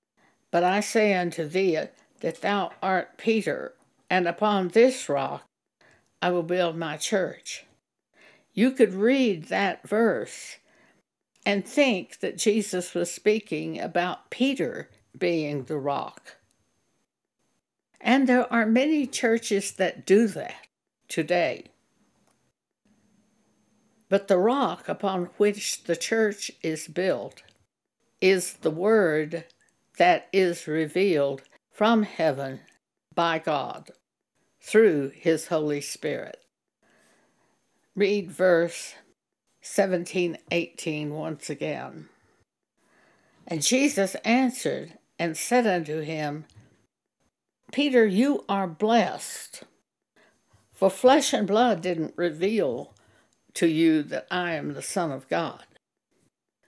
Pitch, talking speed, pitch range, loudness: 190 Hz, 105 wpm, 165-220 Hz, -25 LUFS